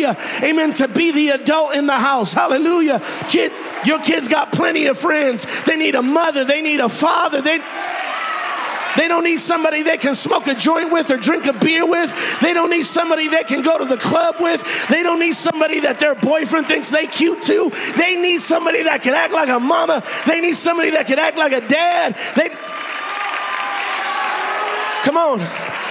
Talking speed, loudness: 190 wpm, -16 LUFS